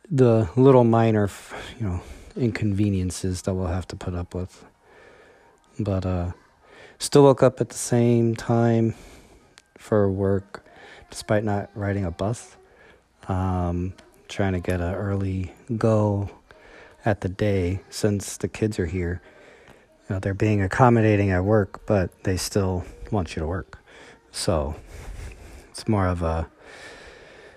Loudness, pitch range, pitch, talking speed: -23 LUFS, 90-110 Hz, 100 Hz, 135 wpm